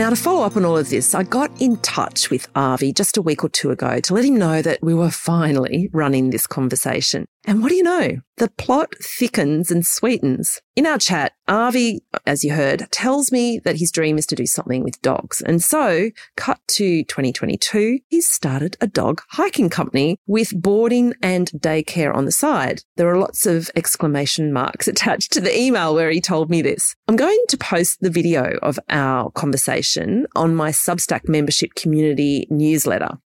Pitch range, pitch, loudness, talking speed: 155-230 Hz, 170 Hz, -18 LUFS, 195 wpm